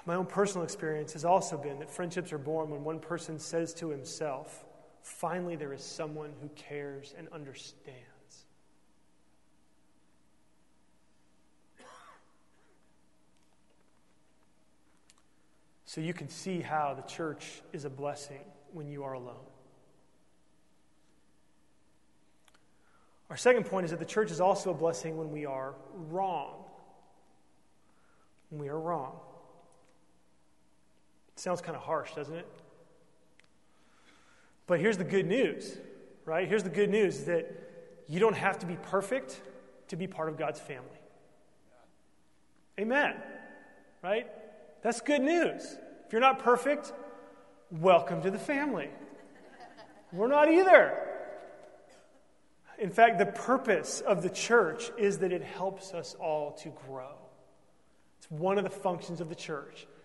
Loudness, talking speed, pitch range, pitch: -31 LUFS, 125 wpm, 150-195 Hz, 170 Hz